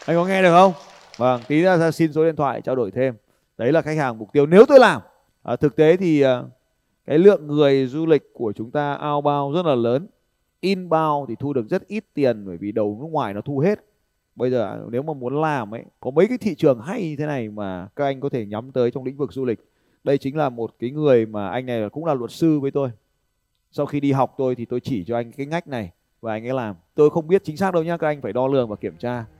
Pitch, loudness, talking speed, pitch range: 140 Hz, -20 LUFS, 270 wpm, 120-160 Hz